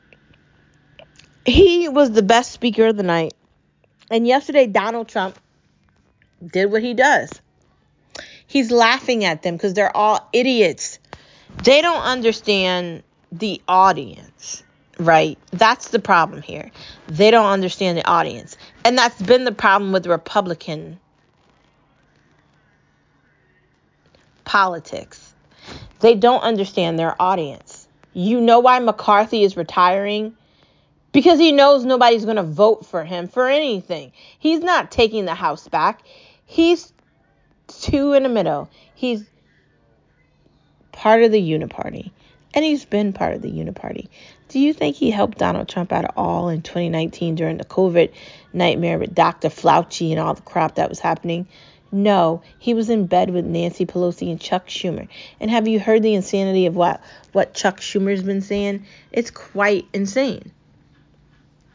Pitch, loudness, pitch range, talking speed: 205 Hz, -18 LUFS, 180-240 Hz, 140 wpm